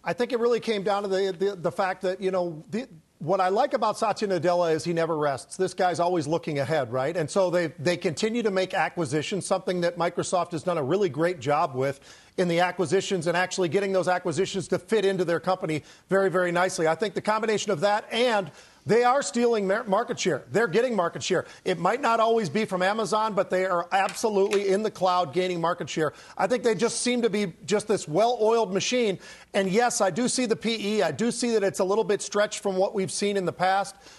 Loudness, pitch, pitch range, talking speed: -25 LUFS, 190 Hz, 175-210 Hz, 235 wpm